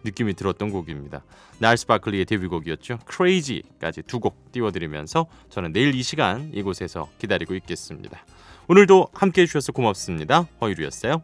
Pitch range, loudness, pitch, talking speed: 95-150 Hz, -22 LUFS, 110 Hz, 410 characters per minute